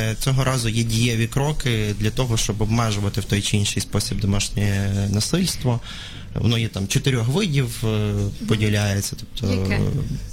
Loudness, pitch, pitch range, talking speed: -22 LUFS, 110 Hz, 100-125 Hz, 135 wpm